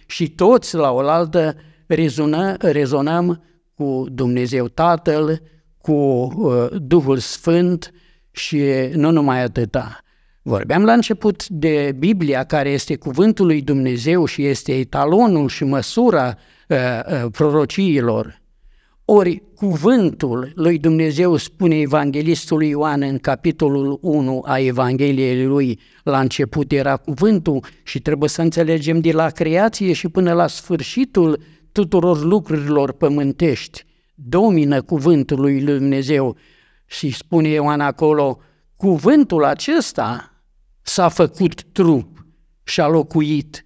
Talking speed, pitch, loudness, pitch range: 105 wpm, 155 Hz, -17 LUFS, 140-175 Hz